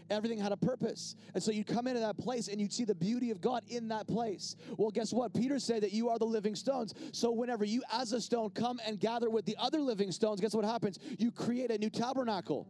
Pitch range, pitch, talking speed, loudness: 210-240 Hz, 225 Hz, 255 wpm, -35 LUFS